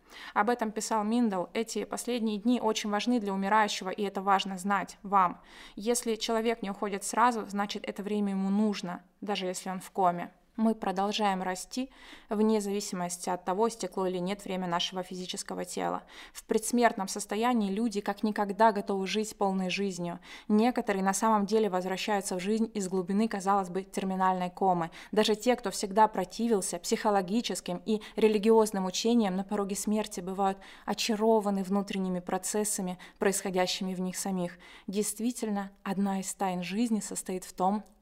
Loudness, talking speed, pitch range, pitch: -30 LUFS, 150 wpm, 190-220 Hz, 200 Hz